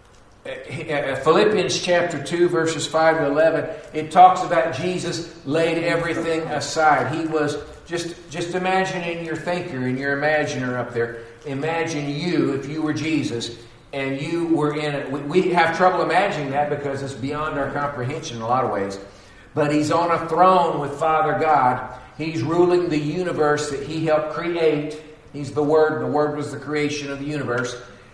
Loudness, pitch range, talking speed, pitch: -21 LUFS, 140-165 Hz, 170 wpm, 155 Hz